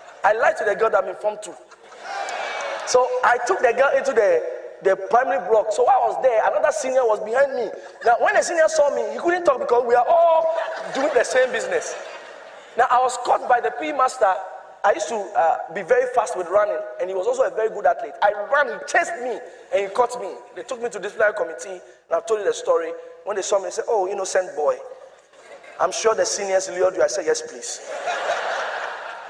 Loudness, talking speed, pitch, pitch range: -21 LUFS, 225 wpm, 245 Hz, 205-340 Hz